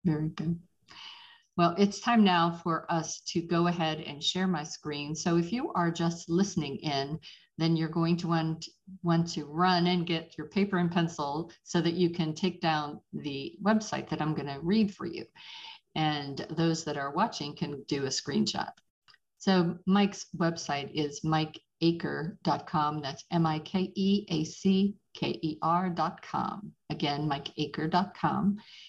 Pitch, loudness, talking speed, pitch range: 170 Hz, -30 LUFS, 145 wpm, 155-185 Hz